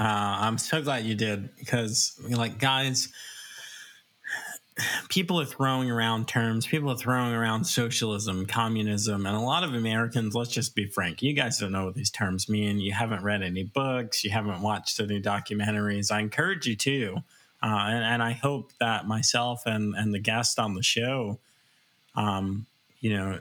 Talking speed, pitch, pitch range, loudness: 175 wpm, 115 Hz, 105-125 Hz, -27 LUFS